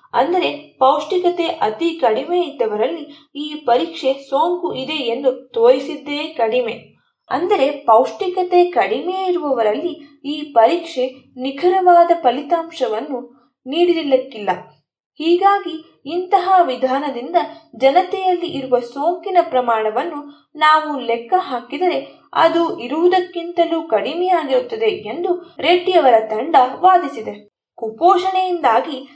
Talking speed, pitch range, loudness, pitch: 80 wpm, 255-355 Hz, -17 LUFS, 310 Hz